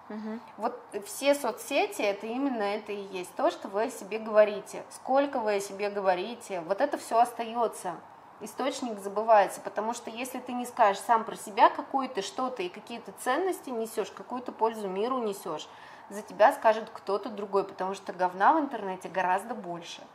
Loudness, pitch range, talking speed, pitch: -29 LUFS, 200-250 Hz, 165 wpm, 220 Hz